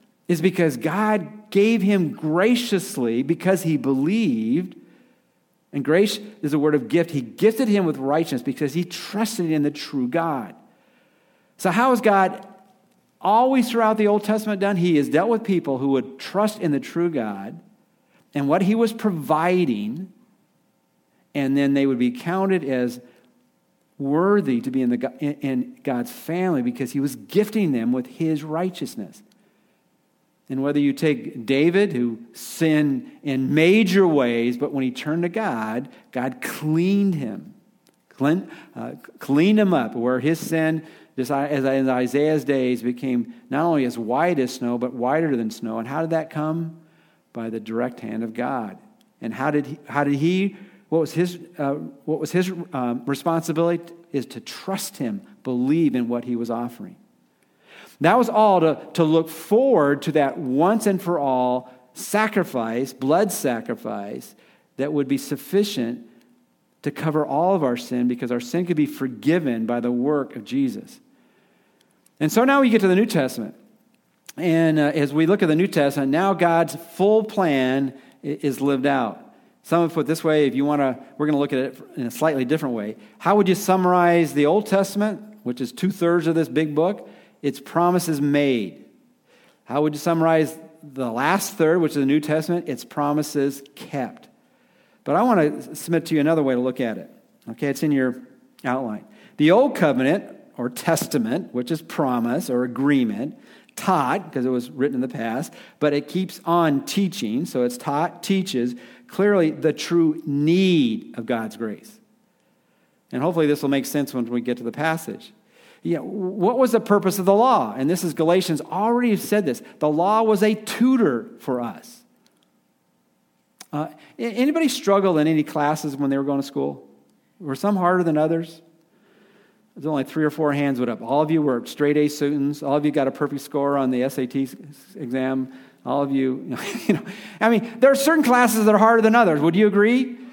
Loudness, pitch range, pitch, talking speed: -21 LUFS, 135-195 Hz, 155 Hz, 180 wpm